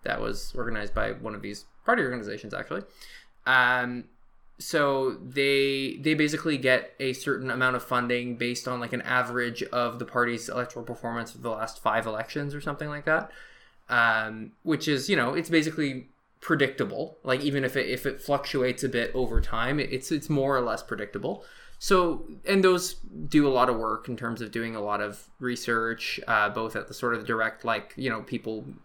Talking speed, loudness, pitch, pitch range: 190 wpm, -27 LUFS, 125 Hz, 115-140 Hz